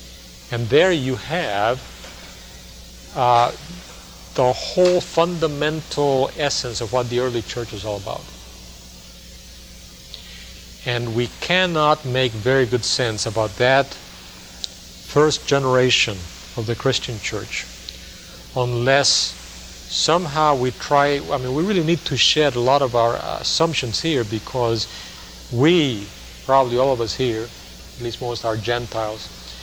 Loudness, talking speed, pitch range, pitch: -20 LUFS, 125 wpm, 95-140 Hz, 120 Hz